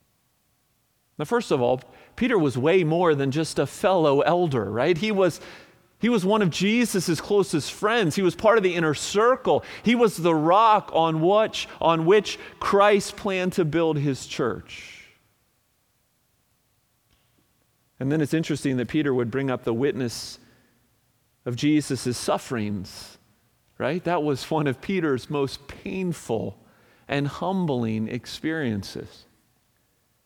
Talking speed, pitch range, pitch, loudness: 135 wpm, 125-185 Hz, 155 Hz, -23 LUFS